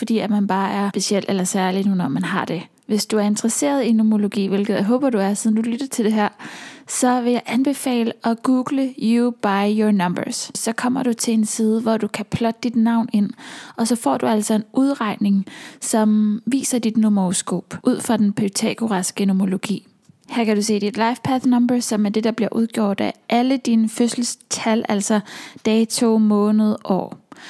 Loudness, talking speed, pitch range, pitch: -19 LUFS, 200 wpm, 210-245 Hz, 225 Hz